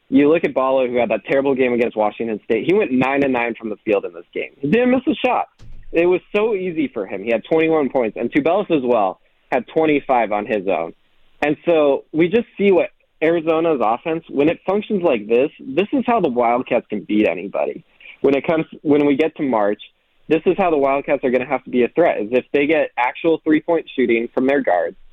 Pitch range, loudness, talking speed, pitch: 125-170 Hz, -18 LUFS, 235 wpm, 145 Hz